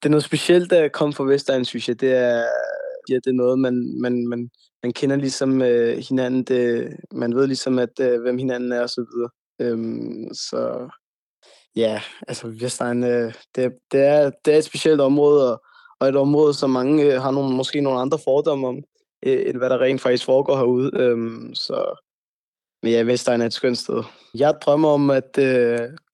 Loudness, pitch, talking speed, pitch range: -20 LUFS, 130 Hz, 195 wpm, 120-145 Hz